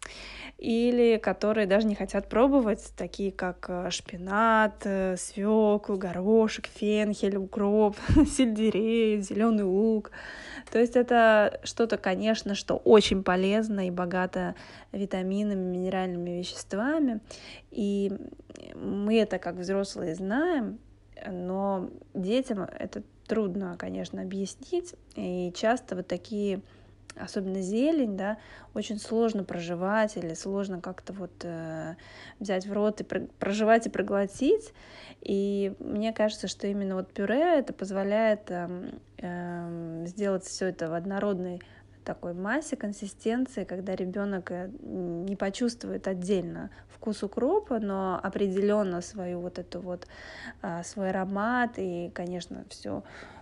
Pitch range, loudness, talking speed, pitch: 185-220 Hz, -29 LUFS, 110 wpm, 200 Hz